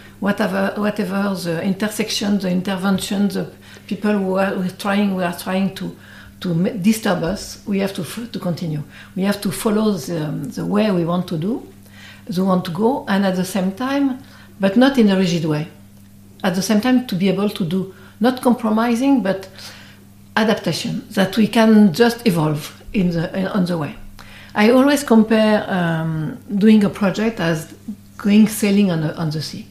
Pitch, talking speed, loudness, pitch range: 195 Hz, 185 wpm, -18 LUFS, 170-215 Hz